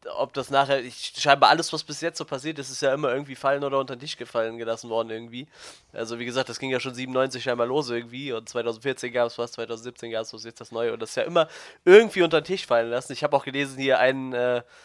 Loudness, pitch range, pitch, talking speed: -25 LUFS, 120-140 Hz, 130 Hz, 265 wpm